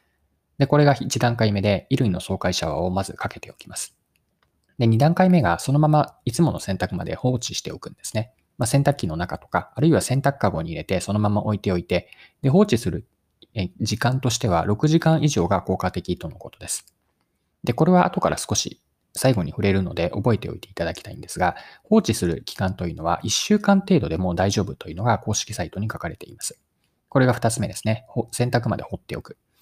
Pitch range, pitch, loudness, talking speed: 90-125 Hz, 105 Hz, -22 LUFS, 395 characters per minute